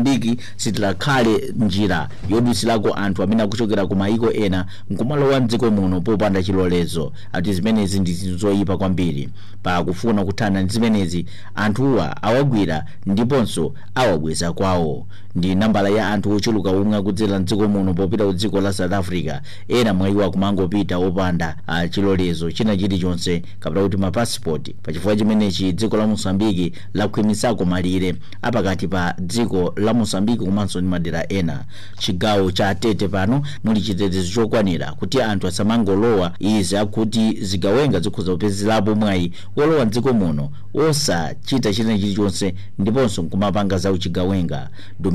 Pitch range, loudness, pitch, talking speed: 95-110 Hz, -19 LUFS, 100 Hz, 95 wpm